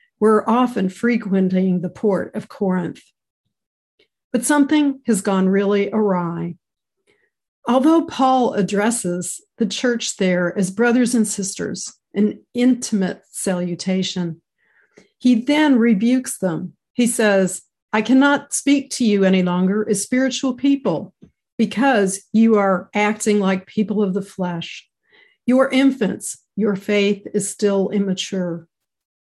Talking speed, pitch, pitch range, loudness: 120 wpm, 210 Hz, 190-250 Hz, -19 LUFS